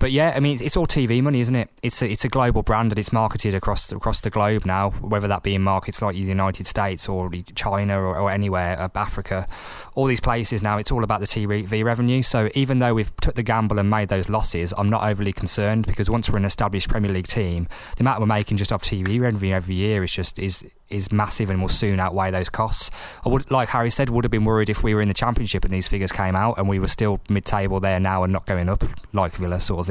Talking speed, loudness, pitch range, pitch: 260 wpm, -22 LUFS, 95-115 Hz, 105 Hz